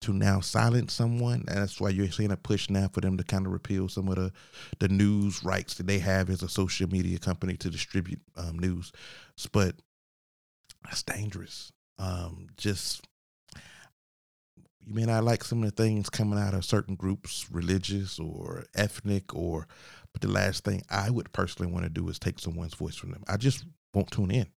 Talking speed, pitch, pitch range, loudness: 195 wpm, 95 Hz, 90-105 Hz, -30 LUFS